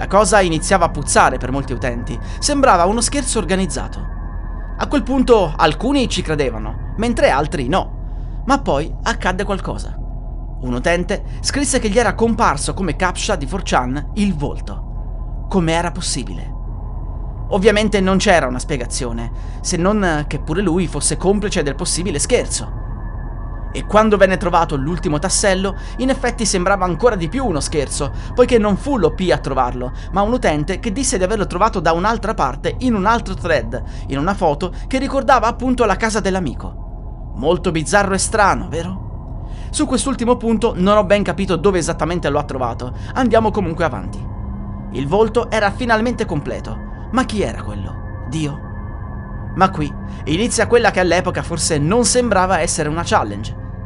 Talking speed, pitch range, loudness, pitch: 160 wpm, 140-220 Hz, -17 LUFS, 185 Hz